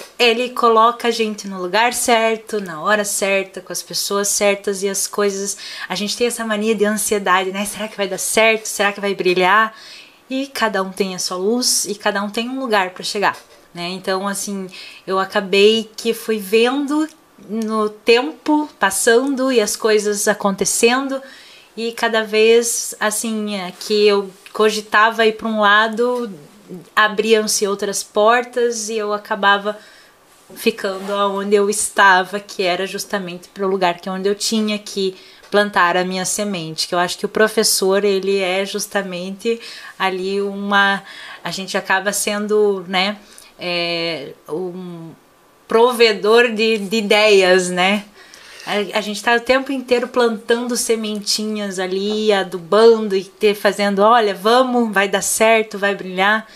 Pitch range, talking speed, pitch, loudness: 195-225 Hz, 155 wpm, 210 Hz, -17 LUFS